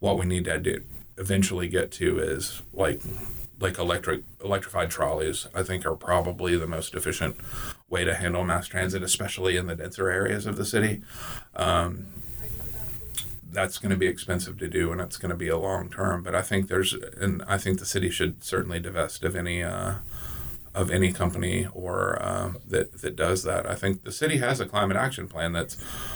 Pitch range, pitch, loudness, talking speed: 90-100 Hz, 95 Hz, -28 LUFS, 190 wpm